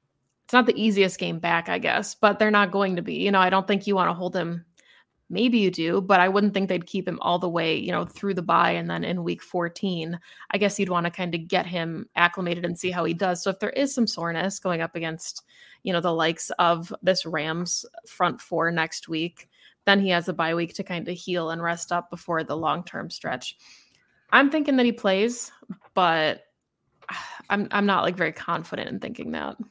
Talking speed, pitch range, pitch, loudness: 230 wpm, 170-200 Hz, 180 Hz, -24 LUFS